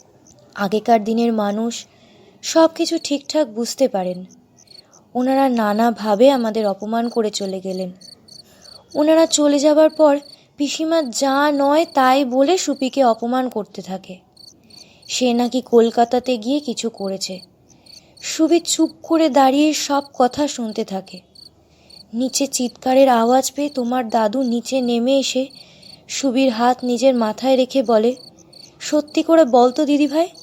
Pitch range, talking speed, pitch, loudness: 225-285 Hz, 120 wpm, 255 Hz, -18 LUFS